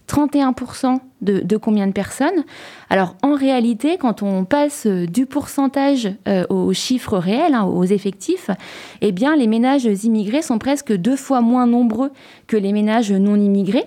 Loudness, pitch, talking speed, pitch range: -18 LUFS, 240 Hz, 160 wpm, 205-275 Hz